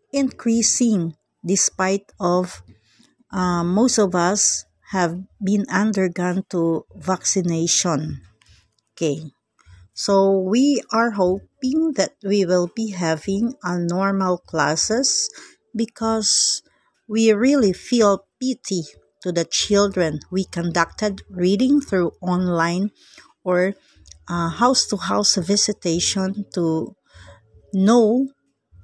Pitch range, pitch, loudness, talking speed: 170-215 Hz, 190 Hz, -20 LUFS, 95 wpm